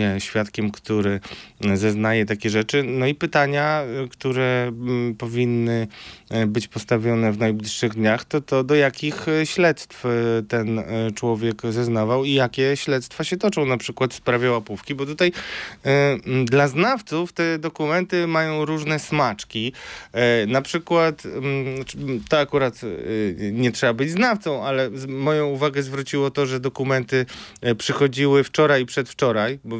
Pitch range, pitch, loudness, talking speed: 115-145 Hz, 130 Hz, -22 LUFS, 125 wpm